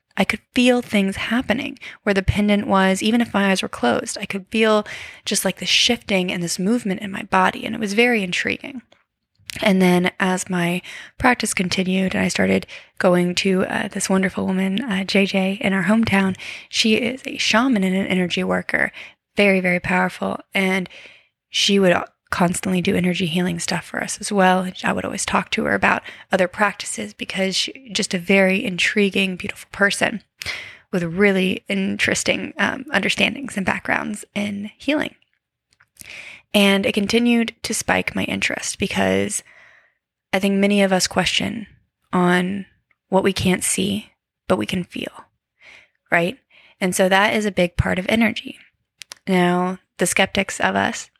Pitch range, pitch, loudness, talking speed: 185-215 Hz, 195 Hz, -20 LUFS, 165 wpm